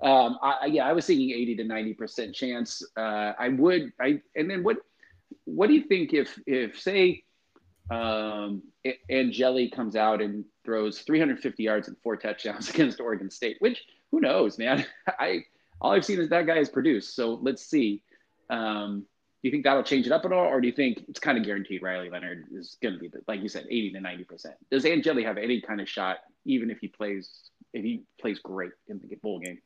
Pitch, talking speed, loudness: 115 Hz, 215 wpm, -27 LUFS